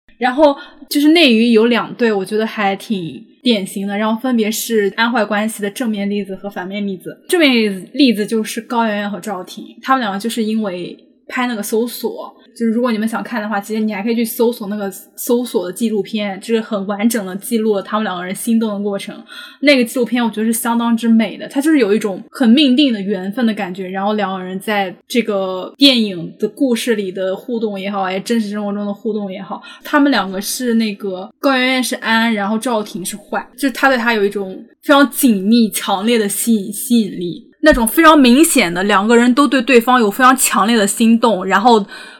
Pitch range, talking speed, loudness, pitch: 205-245 Hz, 325 characters per minute, -15 LUFS, 225 Hz